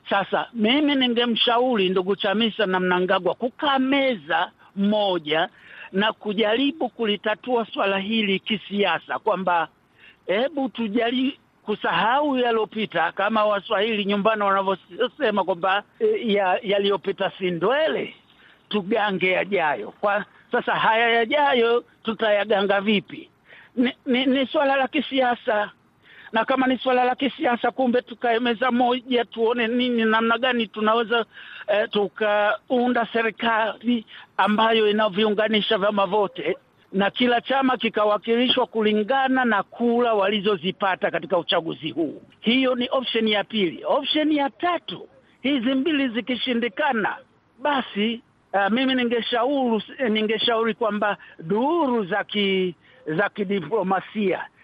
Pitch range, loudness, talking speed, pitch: 200-250 Hz, -22 LUFS, 100 wpm, 225 Hz